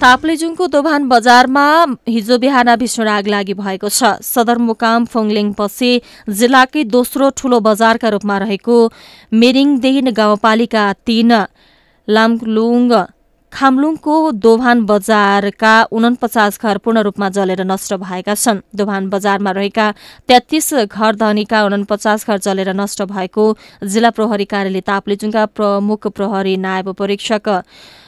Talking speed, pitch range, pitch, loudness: 115 wpm, 205-240 Hz, 220 Hz, -13 LUFS